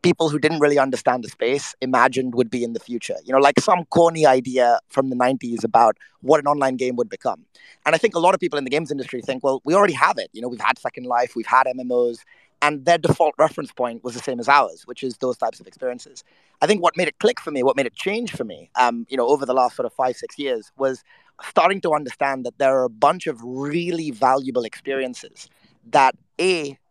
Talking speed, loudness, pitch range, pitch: 250 wpm, -20 LUFS, 125-160 Hz, 135 Hz